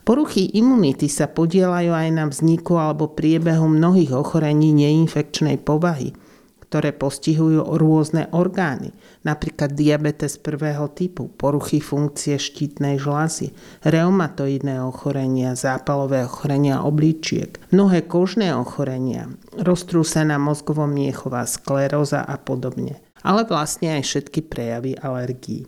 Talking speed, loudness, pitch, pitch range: 105 wpm, -20 LUFS, 150 Hz, 140-165 Hz